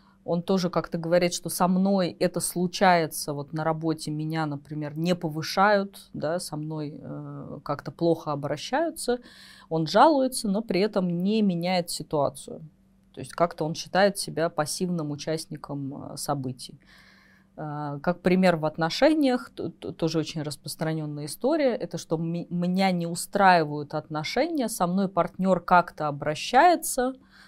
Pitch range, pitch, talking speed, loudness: 155-190 Hz, 170 Hz, 125 wpm, -26 LUFS